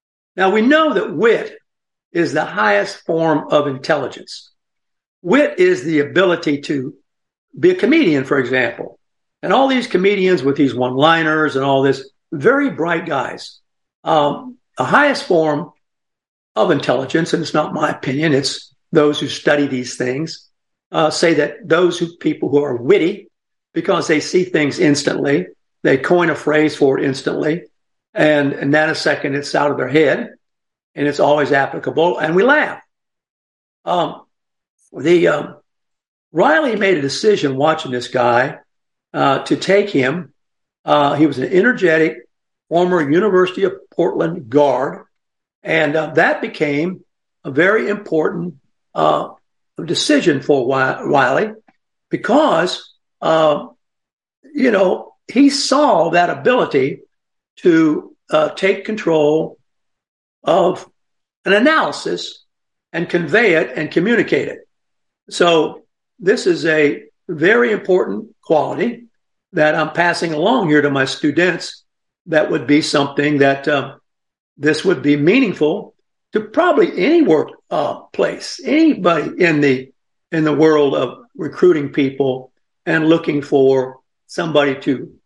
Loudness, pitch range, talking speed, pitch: -16 LUFS, 145-205 Hz, 135 wpm, 160 Hz